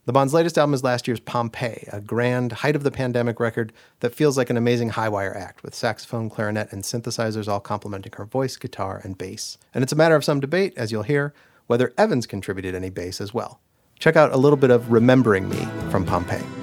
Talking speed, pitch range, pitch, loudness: 225 wpm, 105-130 Hz, 120 Hz, -22 LUFS